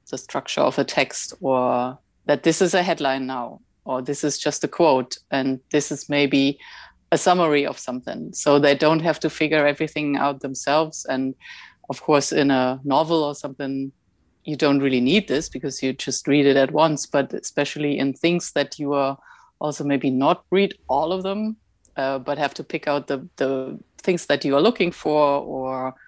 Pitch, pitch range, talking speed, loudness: 145 Hz, 135-155 Hz, 195 wpm, -22 LUFS